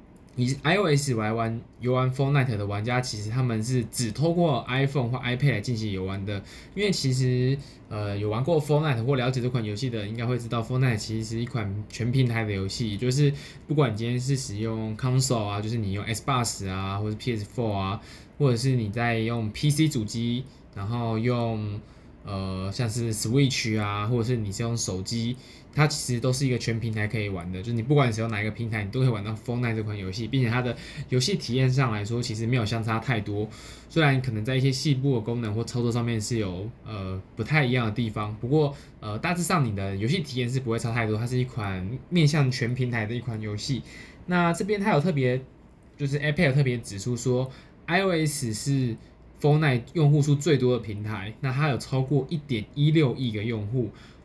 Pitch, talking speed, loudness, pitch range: 120 Hz, 355 characters per minute, -26 LUFS, 110-135 Hz